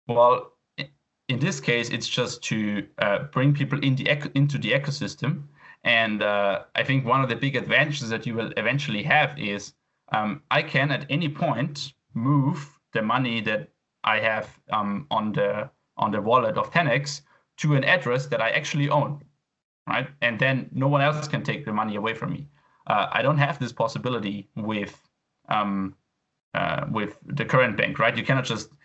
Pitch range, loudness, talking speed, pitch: 115-145 Hz, -24 LUFS, 185 wpm, 135 Hz